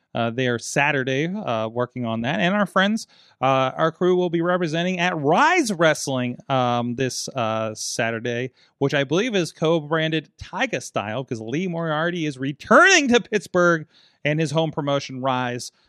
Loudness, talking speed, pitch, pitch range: -21 LUFS, 165 wpm, 150 Hz, 125-175 Hz